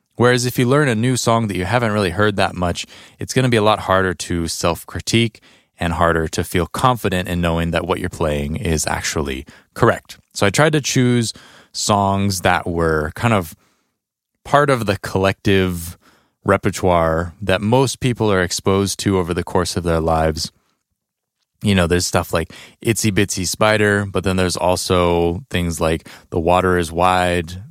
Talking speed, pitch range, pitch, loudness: 180 wpm, 85-110 Hz, 95 Hz, -18 LUFS